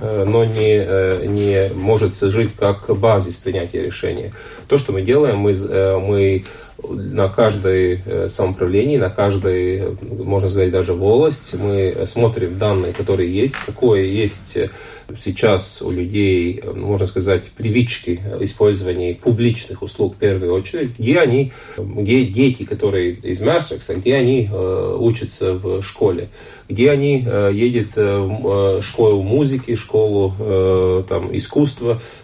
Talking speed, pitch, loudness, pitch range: 120 wpm, 100 Hz, -17 LUFS, 95-115 Hz